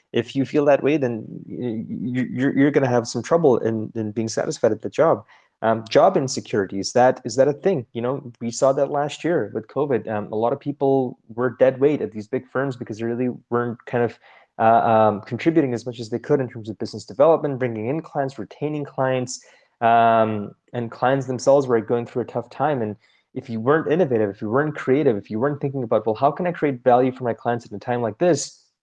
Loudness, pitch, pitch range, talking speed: -21 LUFS, 125 Hz, 115-140 Hz, 225 wpm